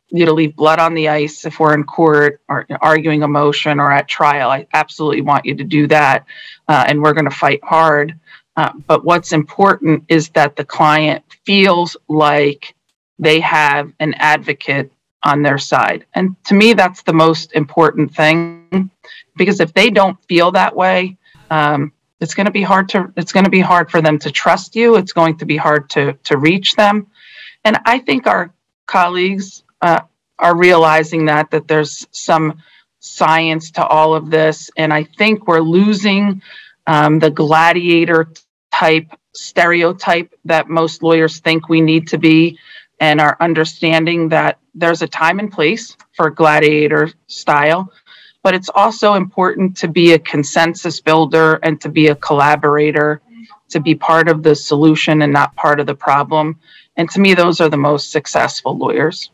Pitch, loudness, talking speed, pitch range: 160 Hz, -13 LUFS, 175 wpm, 150-175 Hz